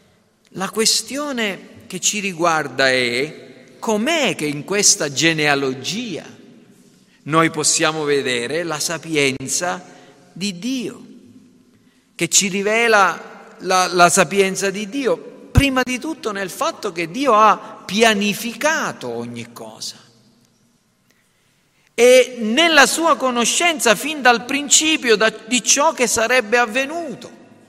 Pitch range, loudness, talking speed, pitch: 165-245 Hz, -17 LUFS, 105 wpm, 215 Hz